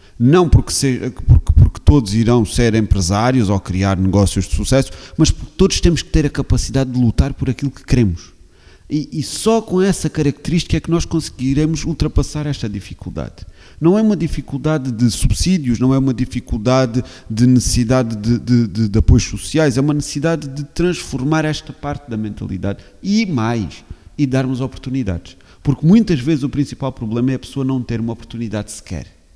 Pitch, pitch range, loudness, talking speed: 125 Hz, 105-145 Hz, -17 LUFS, 175 wpm